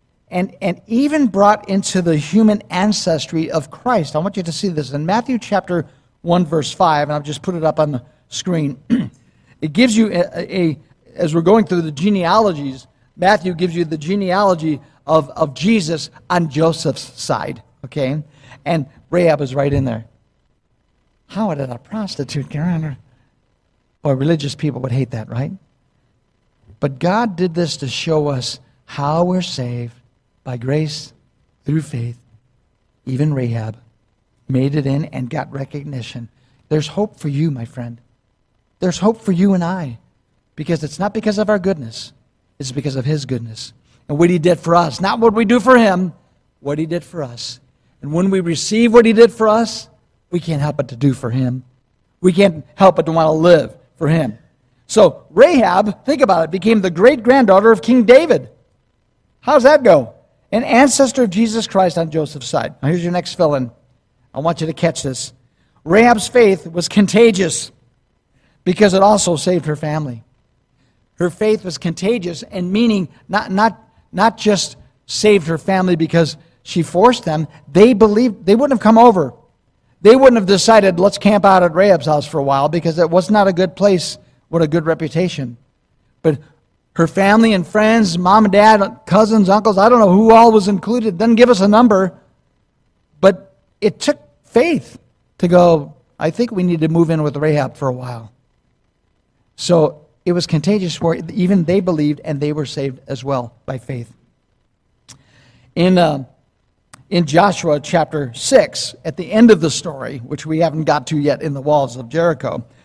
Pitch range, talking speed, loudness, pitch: 135-195 Hz, 180 wpm, -15 LUFS, 160 Hz